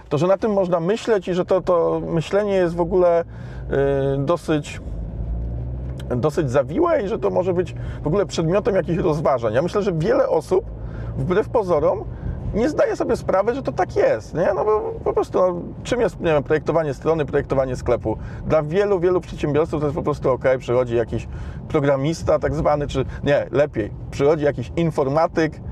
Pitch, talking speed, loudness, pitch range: 155 Hz, 175 wpm, -21 LUFS, 135-180 Hz